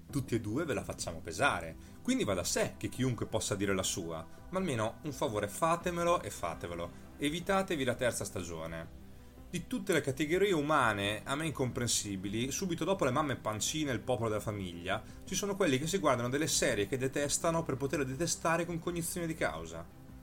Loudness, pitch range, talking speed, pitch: -34 LUFS, 100-165 Hz, 185 wpm, 130 Hz